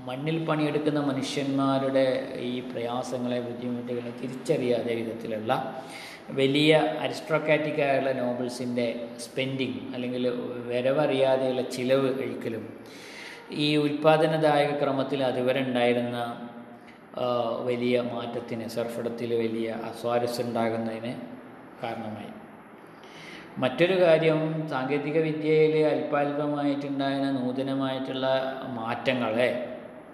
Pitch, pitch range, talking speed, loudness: 130 Hz, 120-145 Hz, 65 wpm, -27 LUFS